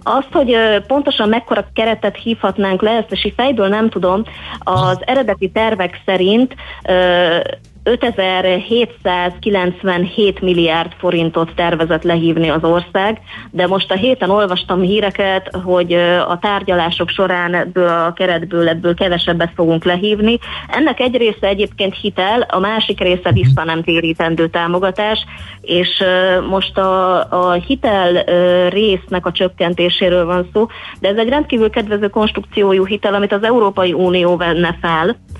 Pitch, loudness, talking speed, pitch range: 185 Hz, -14 LUFS, 130 wpm, 175-210 Hz